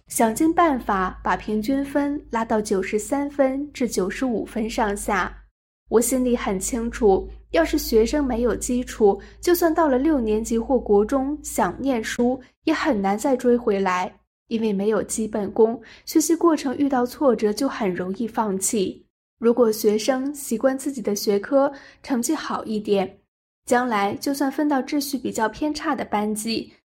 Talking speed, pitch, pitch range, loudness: 240 characters per minute, 240 Hz, 215-280 Hz, -22 LUFS